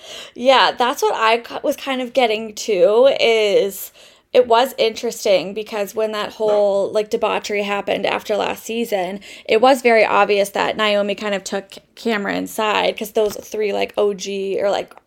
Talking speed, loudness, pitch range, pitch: 165 wpm, -18 LUFS, 205-235 Hz, 215 Hz